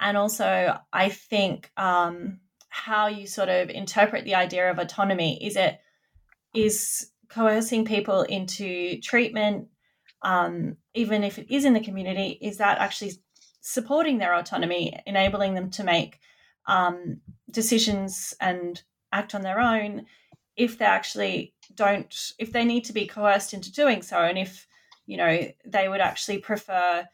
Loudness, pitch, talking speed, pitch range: -25 LUFS, 205 Hz, 150 wpm, 190-225 Hz